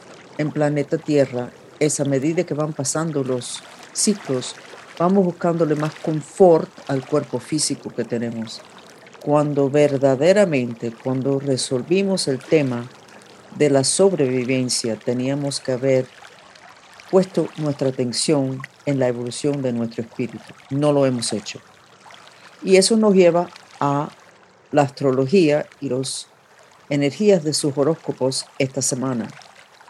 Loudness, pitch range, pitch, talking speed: -20 LUFS, 130-155 Hz, 140 Hz, 120 wpm